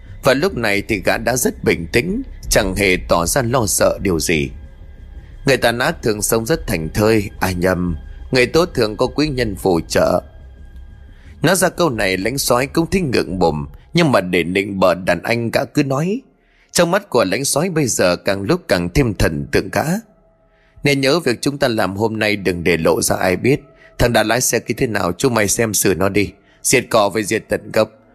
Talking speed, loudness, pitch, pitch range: 215 wpm, -17 LUFS, 110 Hz, 95-135 Hz